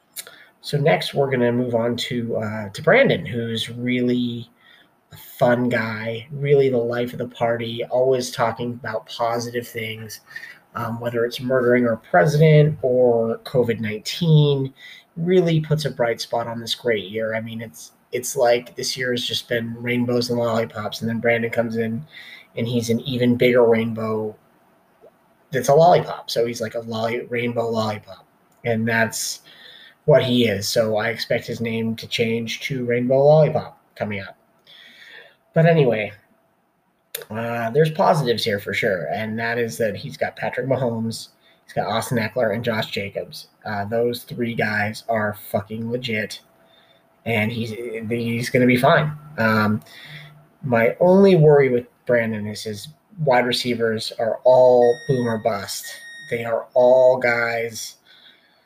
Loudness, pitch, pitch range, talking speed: -20 LUFS, 120 Hz, 115-125 Hz, 150 wpm